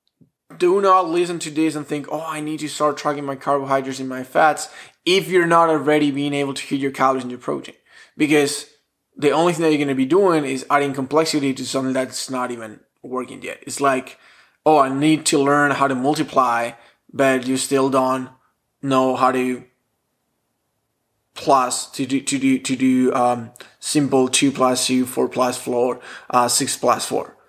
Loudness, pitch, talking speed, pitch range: -19 LUFS, 135 Hz, 190 wpm, 130-150 Hz